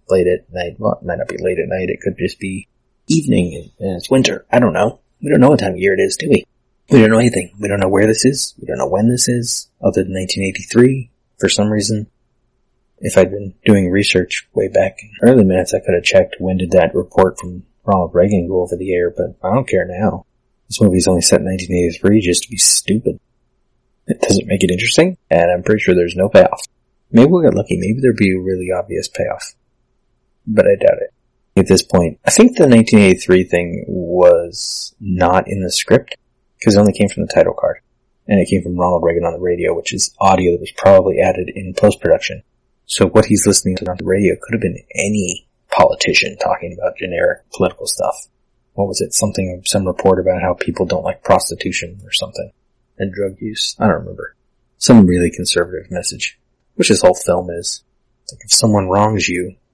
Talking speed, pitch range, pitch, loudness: 220 wpm, 90-110 Hz, 95 Hz, -14 LUFS